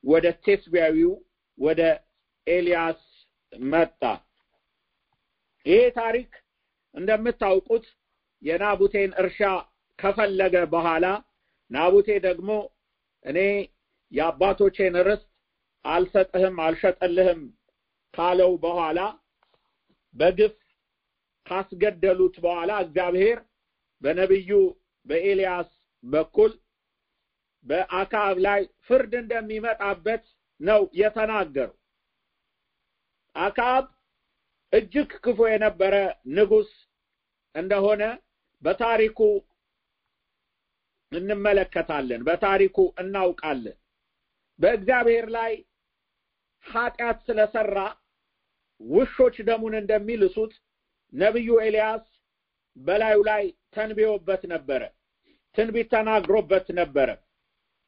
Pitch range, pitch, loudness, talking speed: 185-230 Hz, 205 Hz, -23 LUFS, 60 wpm